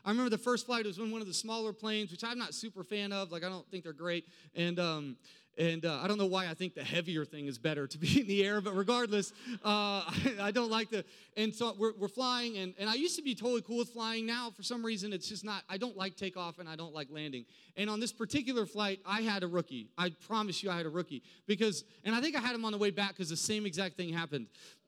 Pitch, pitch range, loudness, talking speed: 205 Hz, 175-225 Hz, -35 LUFS, 280 wpm